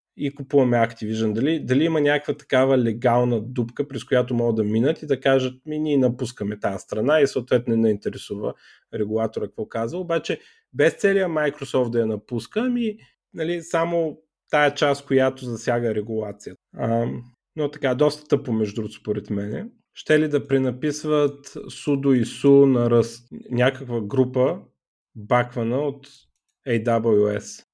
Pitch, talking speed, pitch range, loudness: 130 Hz, 145 wpm, 115-145 Hz, -22 LUFS